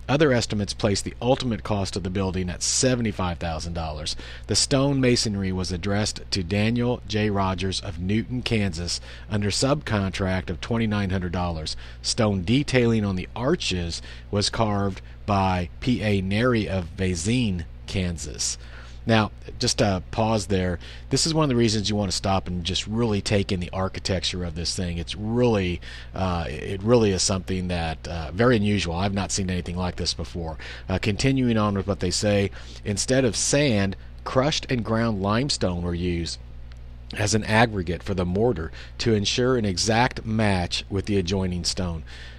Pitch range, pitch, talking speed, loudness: 85-110 Hz, 95 Hz, 165 wpm, -24 LUFS